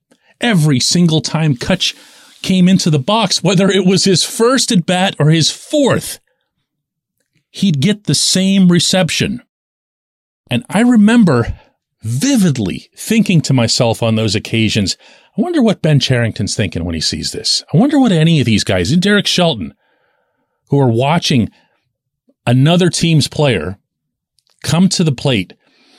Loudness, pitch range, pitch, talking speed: -13 LUFS, 125-190 Hz, 160 Hz, 145 wpm